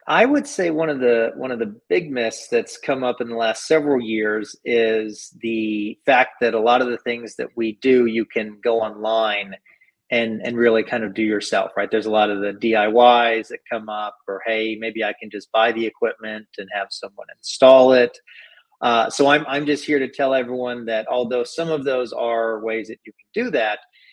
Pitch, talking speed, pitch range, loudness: 115 Hz, 215 wpm, 110-125 Hz, -20 LUFS